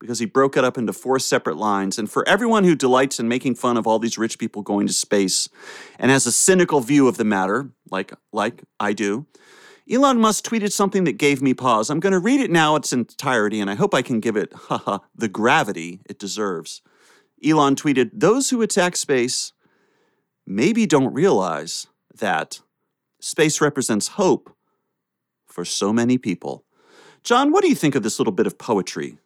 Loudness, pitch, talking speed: -20 LUFS, 135 Hz, 190 wpm